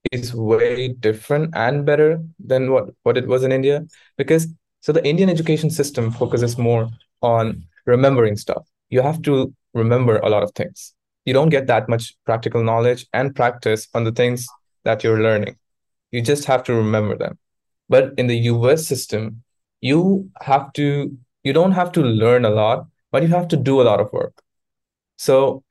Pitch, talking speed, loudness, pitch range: 125 Hz, 180 wpm, -18 LUFS, 115-145 Hz